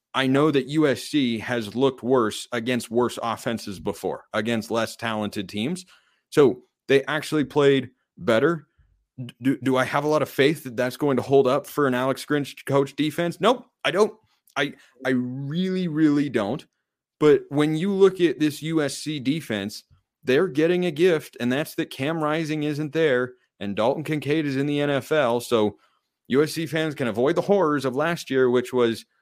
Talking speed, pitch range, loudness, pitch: 175 wpm, 125-155 Hz, -23 LUFS, 145 Hz